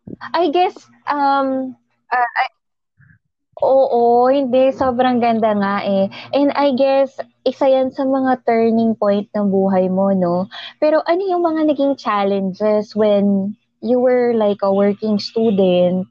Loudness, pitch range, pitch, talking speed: -16 LUFS, 200-270 Hz, 230 Hz, 140 wpm